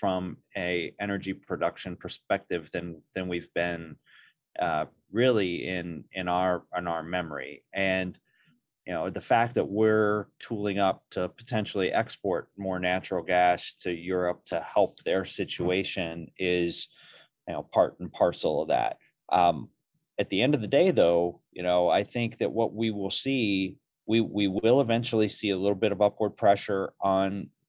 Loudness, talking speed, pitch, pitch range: -28 LUFS, 165 wpm, 95 Hz, 90-105 Hz